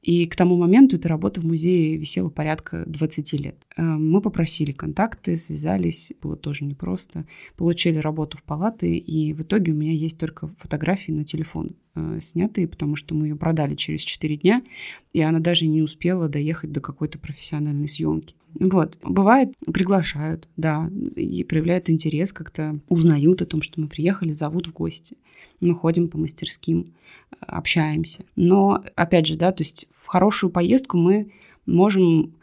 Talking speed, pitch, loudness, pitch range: 155 wpm, 160 Hz, -22 LUFS, 155-180 Hz